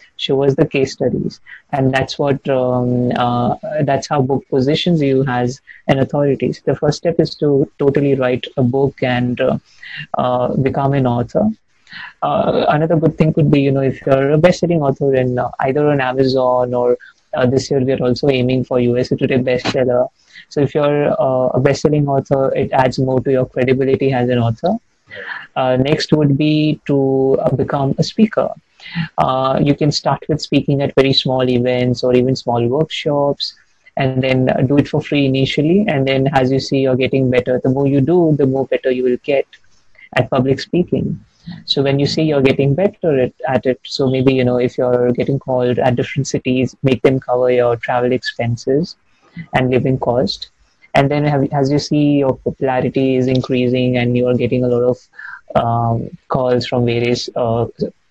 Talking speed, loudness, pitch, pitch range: 185 wpm, -16 LUFS, 135 Hz, 125-145 Hz